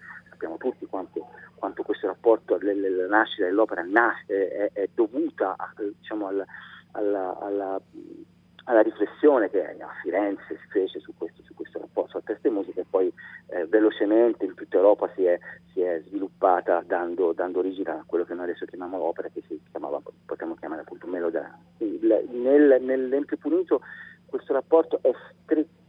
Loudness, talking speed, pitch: -25 LUFS, 170 wpm, 320 Hz